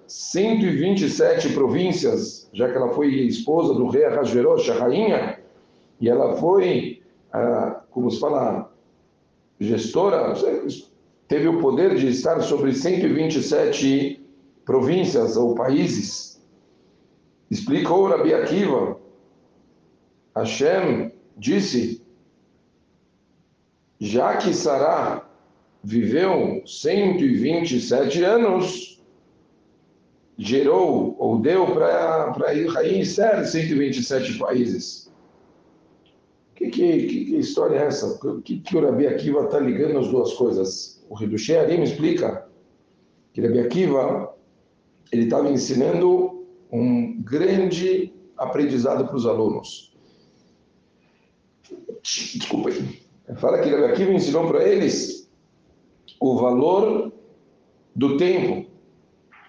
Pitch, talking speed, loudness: 185 Hz, 95 wpm, -21 LUFS